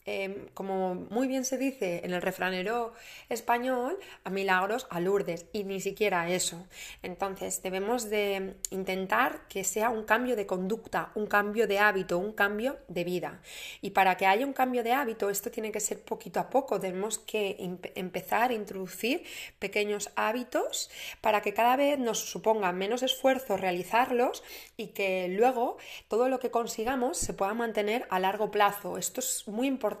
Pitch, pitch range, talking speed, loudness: 210 Hz, 190-240 Hz, 170 wpm, -30 LUFS